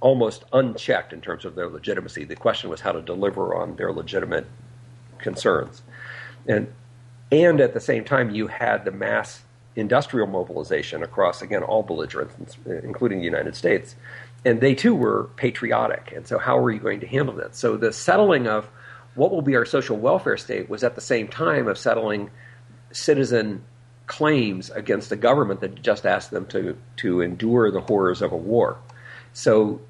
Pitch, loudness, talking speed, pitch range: 120 Hz, -23 LUFS, 175 wpm, 110-125 Hz